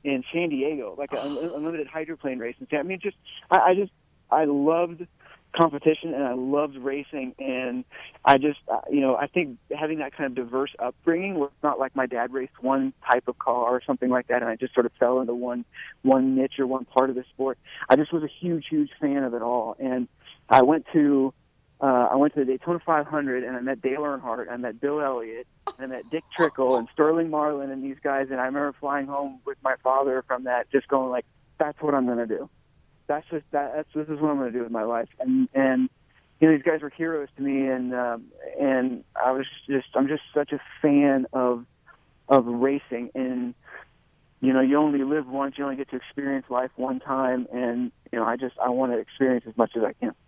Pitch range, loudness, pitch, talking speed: 125-150 Hz, -25 LUFS, 135 Hz, 225 wpm